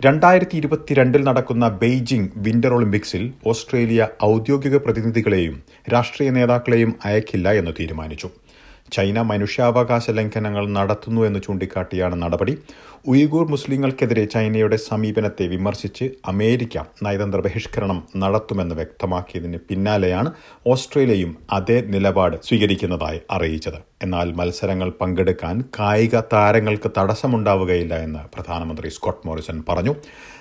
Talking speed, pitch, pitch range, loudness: 95 wpm, 105 Hz, 95-120 Hz, -20 LUFS